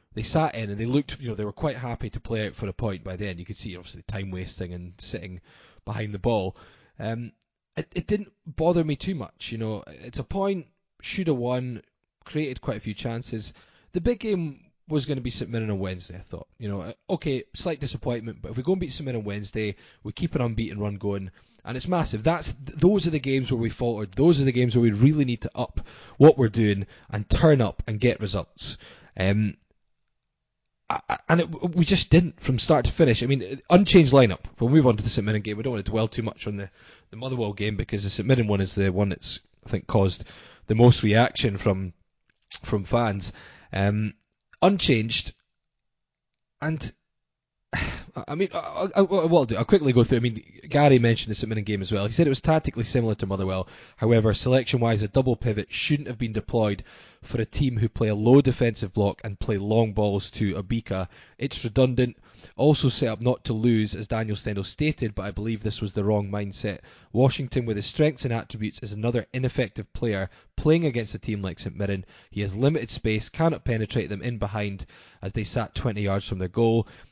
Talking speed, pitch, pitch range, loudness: 215 wpm, 115 Hz, 105-135 Hz, -25 LUFS